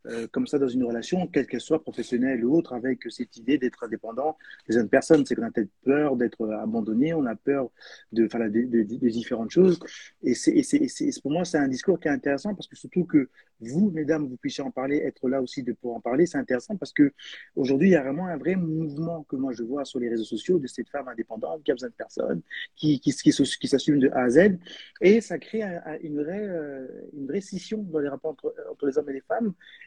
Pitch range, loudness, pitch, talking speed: 125-175 Hz, -26 LUFS, 145 Hz, 255 wpm